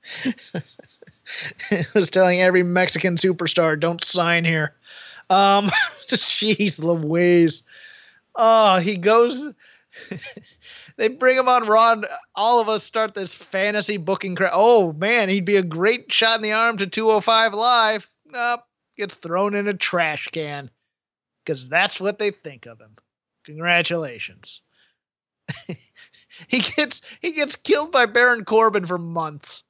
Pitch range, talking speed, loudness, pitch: 175-230 Hz, 135 wpm, -19 LUFS, 205 Hz